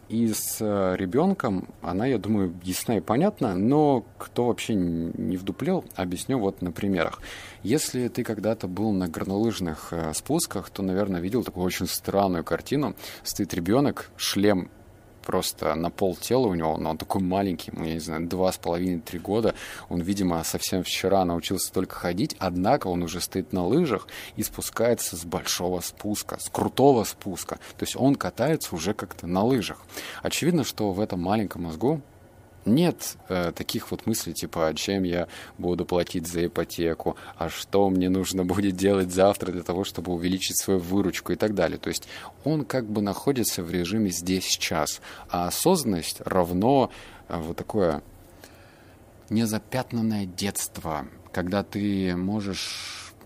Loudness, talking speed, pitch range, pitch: -26 LUFS, 150 wpm, 90-110 Hz, 95 Hz